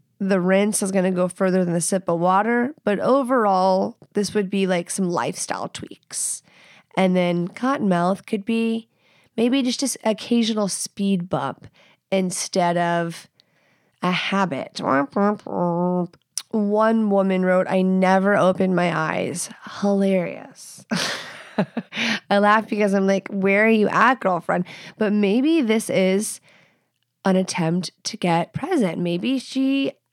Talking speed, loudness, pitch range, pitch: 130 wpm, -21 LUFS, 180-215 Hz, 195 Hz